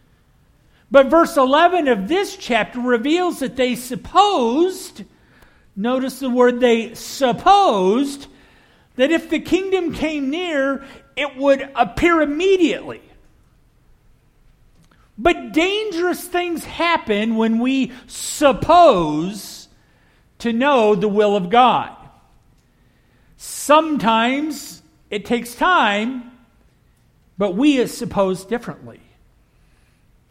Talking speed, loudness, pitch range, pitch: 95 wpm, -17 LUFS, 230-325 Hz, 265 Hz